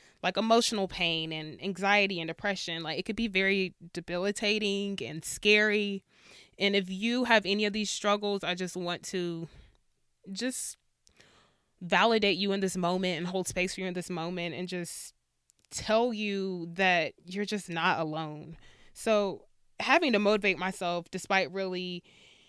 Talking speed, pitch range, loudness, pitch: 150 wpm, 175-205 Hz, -29 LUFS, 190 Hz